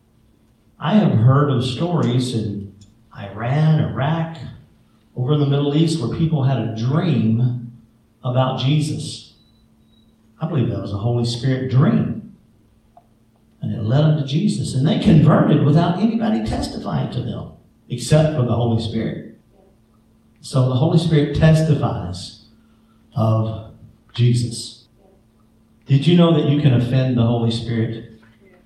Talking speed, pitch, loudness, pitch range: 135 wpm, 120 Hz, -18 LUFS, 115-150 Hz